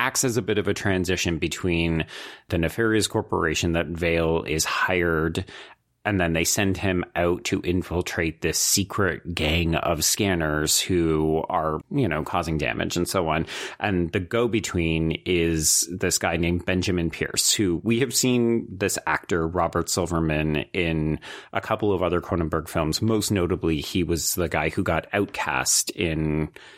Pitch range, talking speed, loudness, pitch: 80-95 Hz, 160 wpm, -24 LUFS, 85 Hz